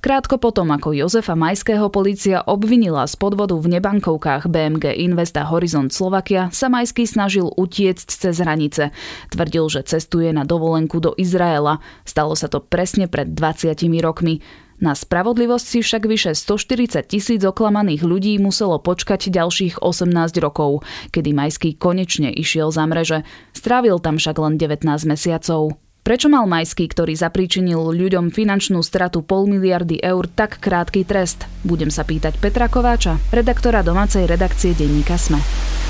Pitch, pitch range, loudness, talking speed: 175 Hz, 160-200 Hz, -18 LUFS, 145 wpm